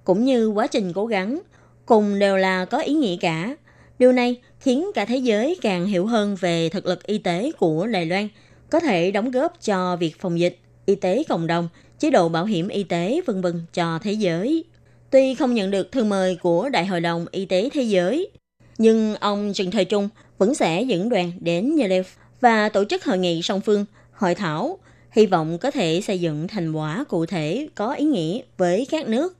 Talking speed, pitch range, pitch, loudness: 210 wpm, 175-245 Hz, 195 Hz, -21 LUFS